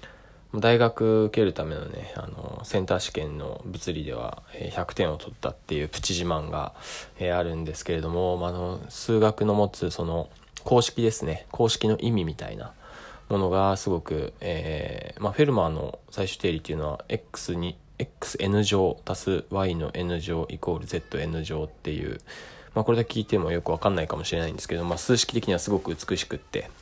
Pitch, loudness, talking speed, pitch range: 90 Hz, -27 LUFS, 350 characters per minute, 80-105 Hz